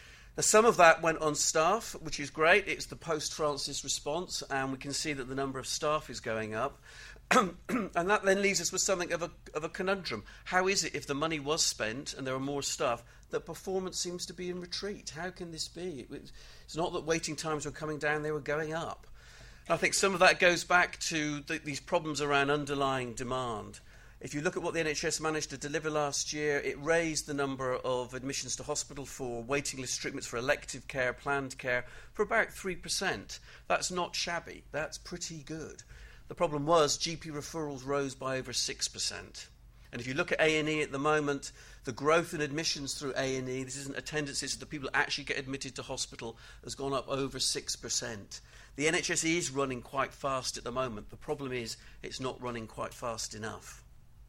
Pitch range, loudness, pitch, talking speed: 130-165 Hz, -32 LUFS, 145 Hz, 205 wpm